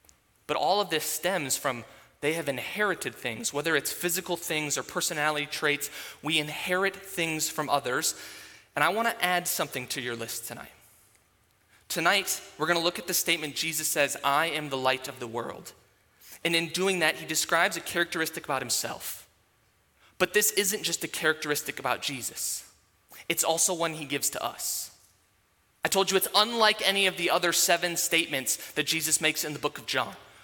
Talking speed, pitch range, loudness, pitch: 185 wpm, 130-175 Hz, -27 LUFS, 155 Hz